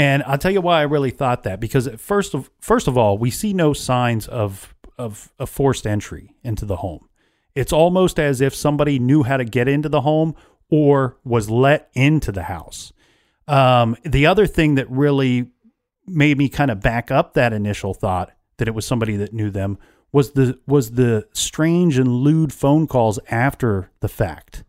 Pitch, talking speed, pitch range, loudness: 135 Hz, 190 wpm, 115-145 Hz, -18 LUFS